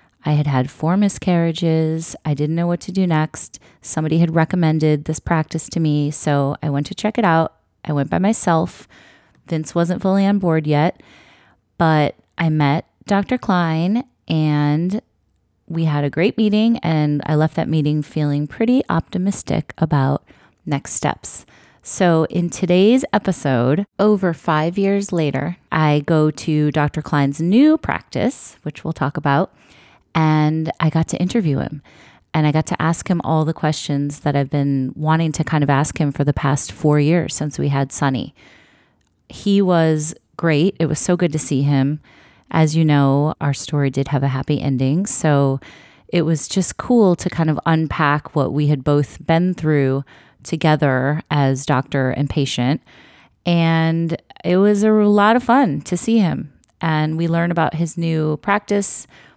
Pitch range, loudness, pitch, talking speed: 145-175 Hz, -18 LUFS, 160 Hz, 170 wpm